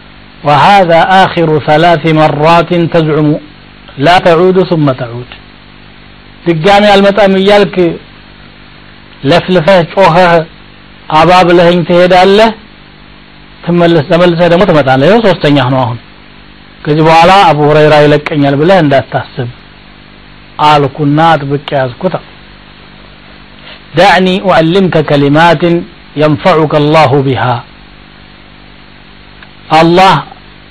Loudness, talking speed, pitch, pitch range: -7 LUFS, 85 wpm, 165 Hz, 150-180 Hz